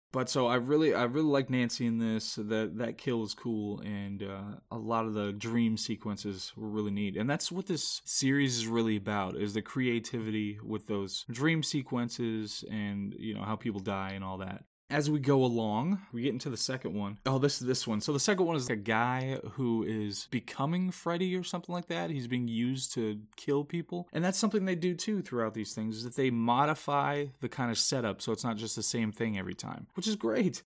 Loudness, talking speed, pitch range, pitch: -32 LUFS, 225 wpm, 110-140 Hz, 120 Hz